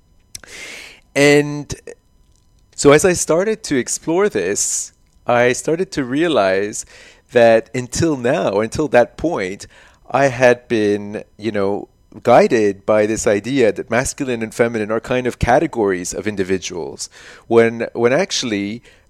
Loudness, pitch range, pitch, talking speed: -17 LUFS, 105-125 Hz, 115 Hz, 125 wpm